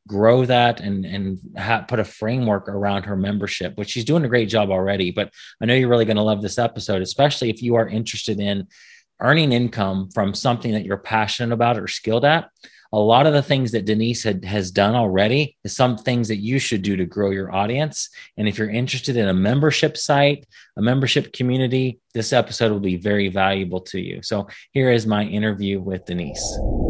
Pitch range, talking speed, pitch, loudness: 100-125 Hz, 205 wpm, 110 Hz, -20 LUFS